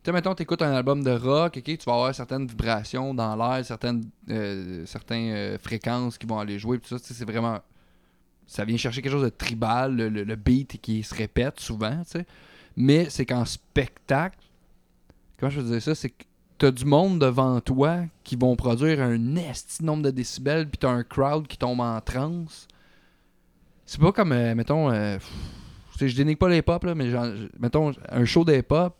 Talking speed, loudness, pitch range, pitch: 205 wpm, -25 LUFS, 115-145 Hz, 125 Hz